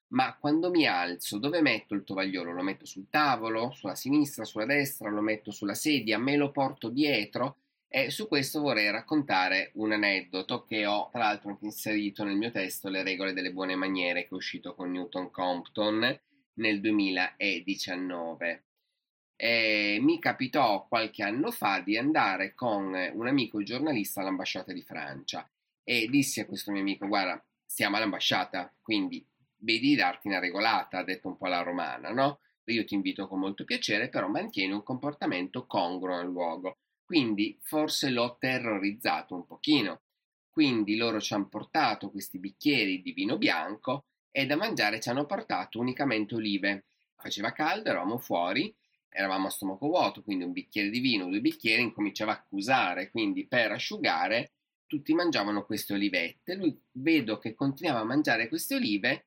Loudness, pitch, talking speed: -30 LUFS, 110 Hz, 160 wpm